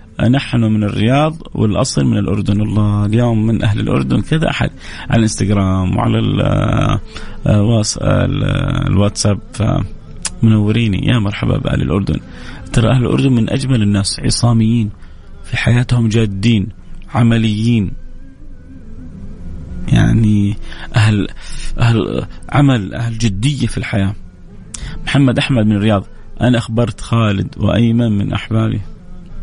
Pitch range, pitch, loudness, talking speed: 100-120 Hz, 110 Hz, -15 LUFS, 105 wpm